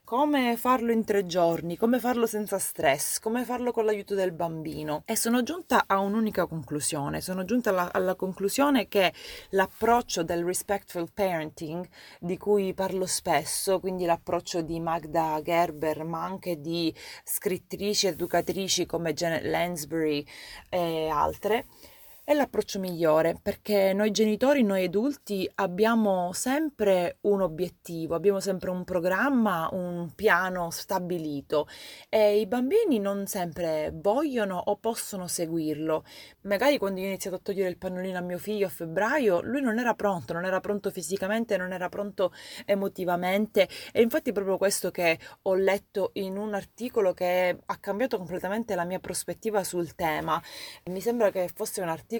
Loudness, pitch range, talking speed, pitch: -28 LUFS, 175-210 Hz, 150 wpm, 190 Hz